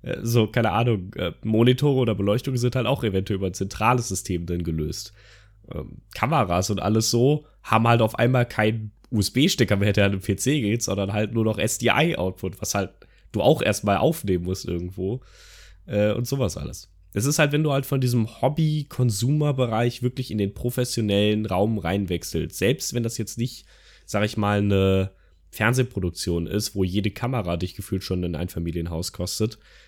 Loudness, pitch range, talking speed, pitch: -23 LUFS, 95-120 Hz, 175 wpm, 105 Hz